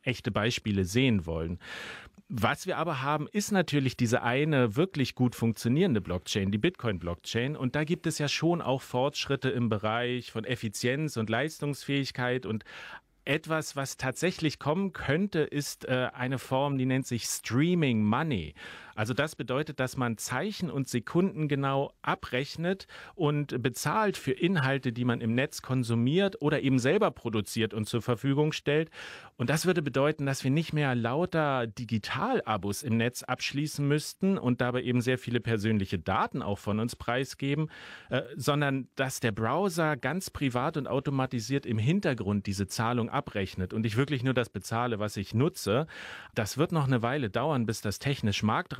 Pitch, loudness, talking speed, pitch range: 130 Hz, -30 LUFS, 160 wpm, 115-150 Hz